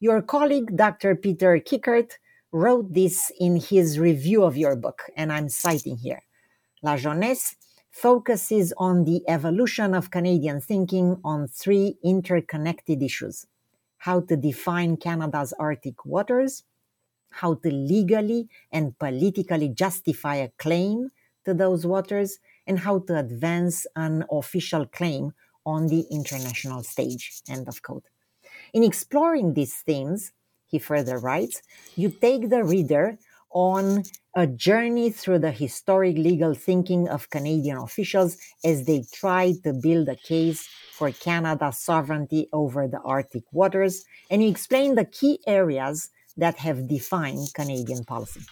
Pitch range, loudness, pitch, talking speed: 150-195 Hz, -24 LUFS, 170 Hz, 135 wpm